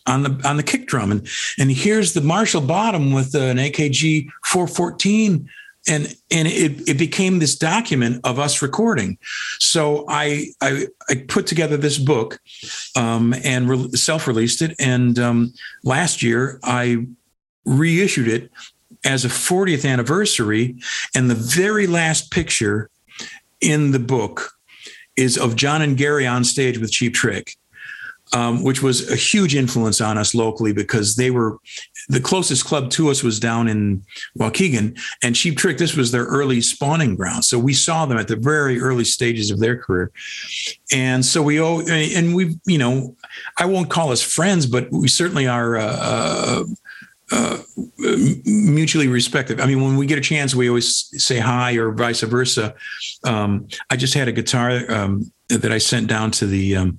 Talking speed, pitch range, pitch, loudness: 170 wpm, 120-155 Hz, 130 Hz, -18 LUFS